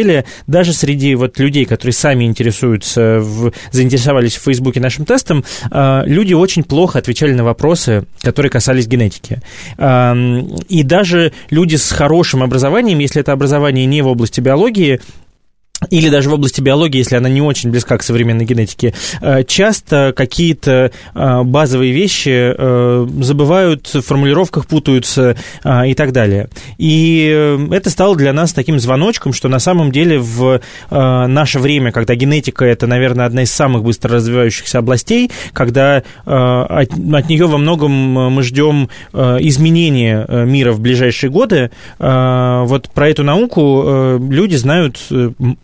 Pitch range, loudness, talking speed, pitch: 125-150 Hz, -12 LUFS, 135 wpm, 135 Hz